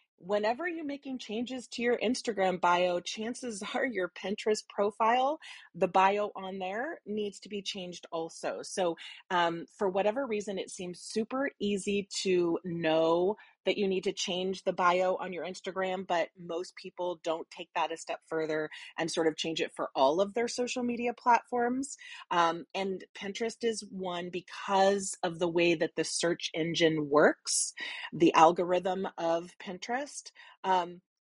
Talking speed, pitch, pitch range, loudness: 160 wpm, 190 Hz, 175-230 Hz, -31 LUFS